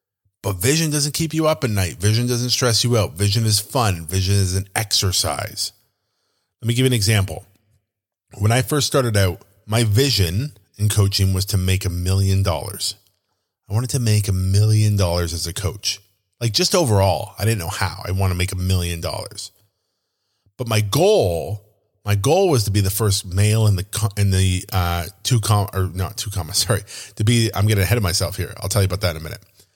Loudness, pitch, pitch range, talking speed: -19 LUFS, 105 Hz, 95-110 Hz, 210 wpm